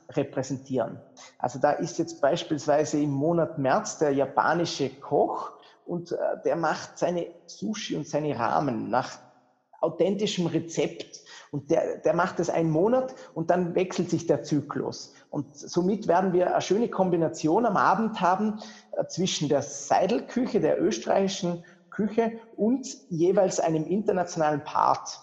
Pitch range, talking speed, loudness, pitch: 150-190 Hz, 135 wpm, -27 LUFS, 170 Hz